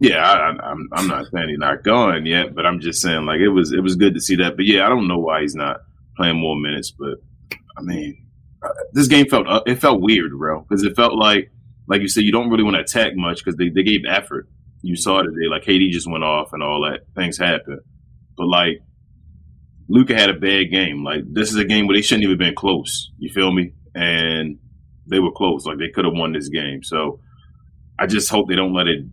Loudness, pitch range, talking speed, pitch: -17 LUFS, 80-100 Hz, 240 wpm, 90 Hz